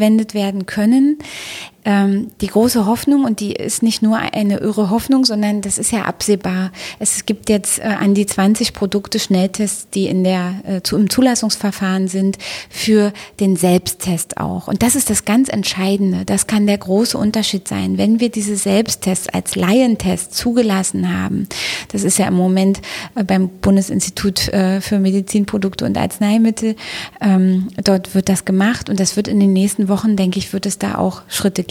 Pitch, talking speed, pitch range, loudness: 200 Hz, 165 wpm, 190-215 Hz, -16 LUFS